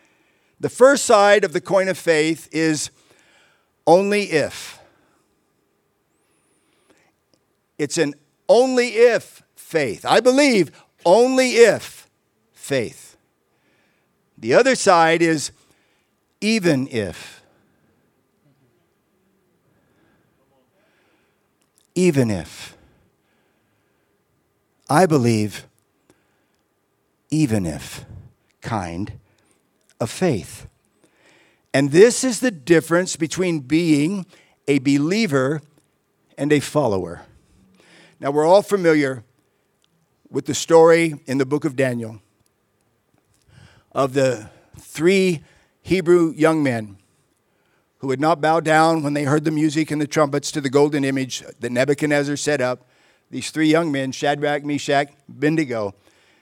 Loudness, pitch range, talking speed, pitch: -19 LUFS, 130-165 Hz, 100 wpm, 150 Hz